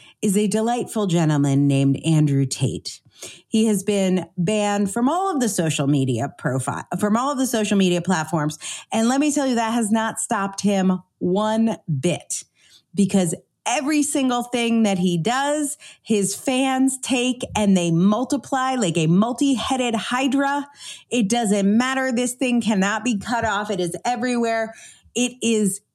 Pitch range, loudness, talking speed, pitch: 185-245 Hz, -21 LUFS, 155 wpm, 215 Hz